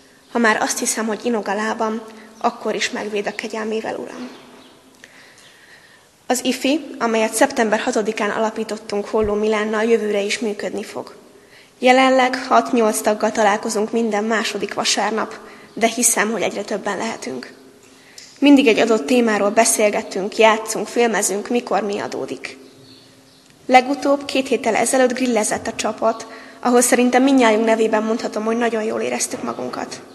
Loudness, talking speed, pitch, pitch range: -18 LUFS, 130 wpm, 220 Hz, 210-240 Hz